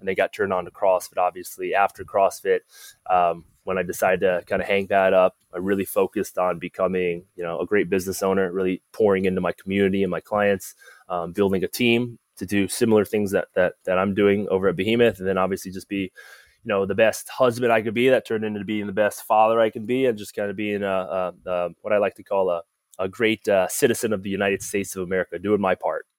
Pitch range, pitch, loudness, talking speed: 95-110 Hz, 100 Hz, -23 LUFS, 240 wpm